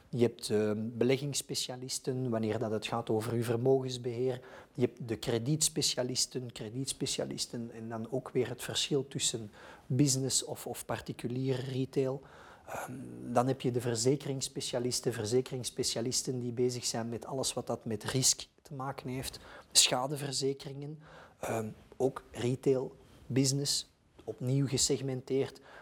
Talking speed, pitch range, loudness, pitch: 125 wpm, 120-135 Hz, -33 LUFS, 130 Hz